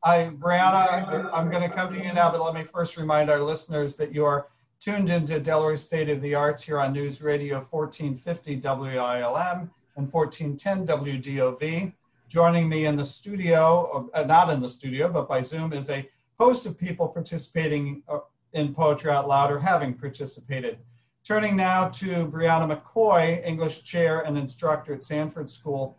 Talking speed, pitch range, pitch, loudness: 165 wpm, 140-170 Hz, 155 Hz, -25 LUFS